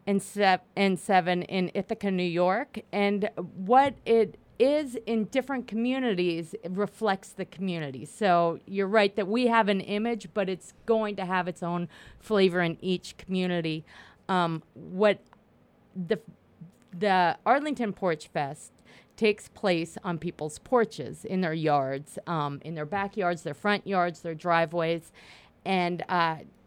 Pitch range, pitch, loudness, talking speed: 170-210 Hz, 185 Hz, -28 LUFS, 145 wpm